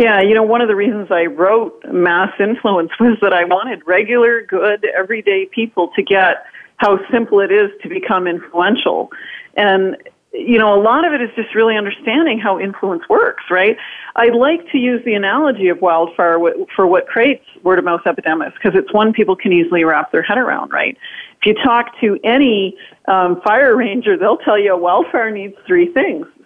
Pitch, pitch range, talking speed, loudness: 210 Hz, 190-235 Hz, 185 wpm, -14 LUFS